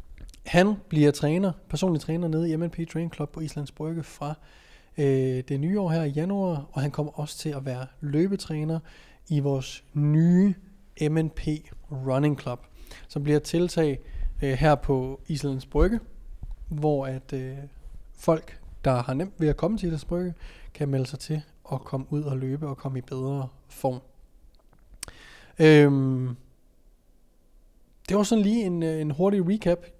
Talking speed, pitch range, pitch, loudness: 160 wpm, 135-165 Hz, 150 Hz, -26 LUFS